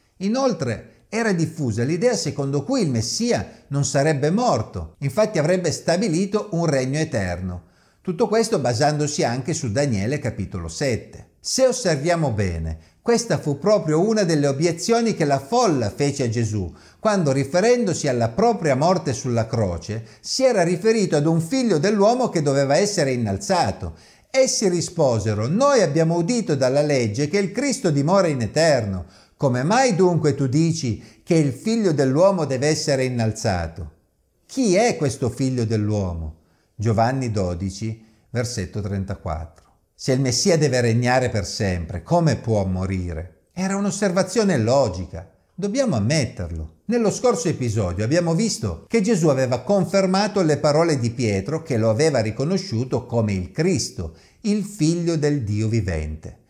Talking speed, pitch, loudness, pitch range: 140 wpm, 140 Hz, -21 LUFS, 110-180 Hz